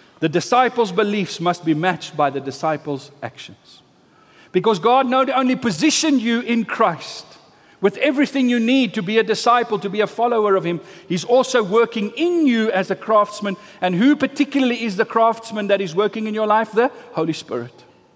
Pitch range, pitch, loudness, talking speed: 185-240 Hz, 220 Hz, -19 LUFS, 180 wpm